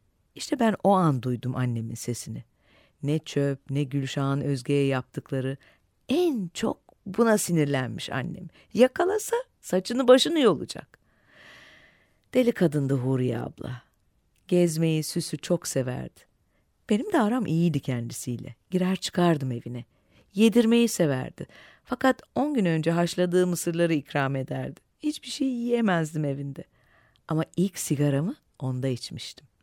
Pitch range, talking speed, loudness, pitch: 130-200 Hz, 115 wpm, -26 LUFS, 160 Hz